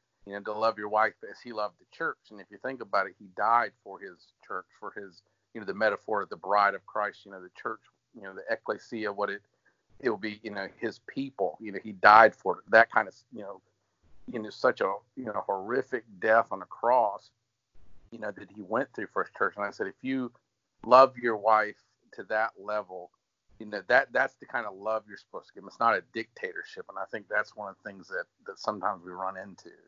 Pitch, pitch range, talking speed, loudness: 110 Hz, 105-130 Hz, 245 wpm, -28 LUFS